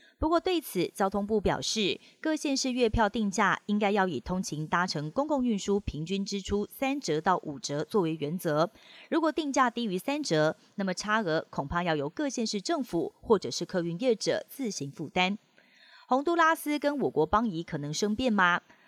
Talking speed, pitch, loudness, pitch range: 275 characters per minute, 200 Hz, -29 LUFS, 170-260 Hz